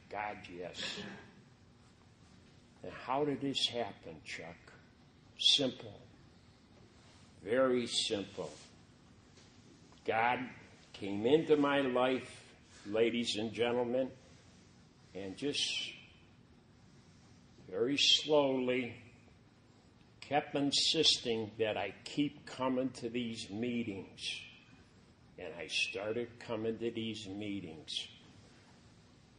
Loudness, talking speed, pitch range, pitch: -34 LUFS, 80 wpm, 110-130 Hz, 120 Hz